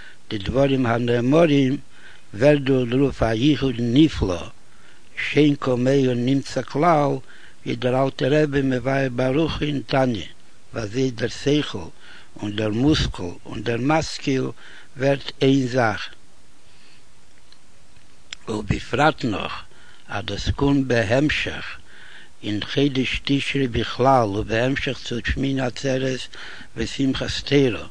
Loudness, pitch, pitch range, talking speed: -21 LUFS, 130 Hz, 115-140 Hz, 125 wpm